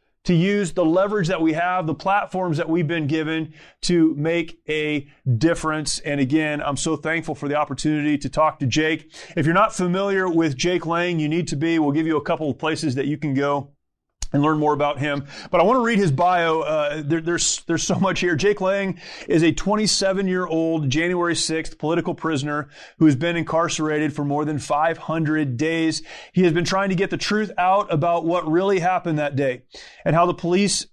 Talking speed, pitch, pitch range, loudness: 210 wpm, 160 Hz, 150-175 Hz, -21 LUFS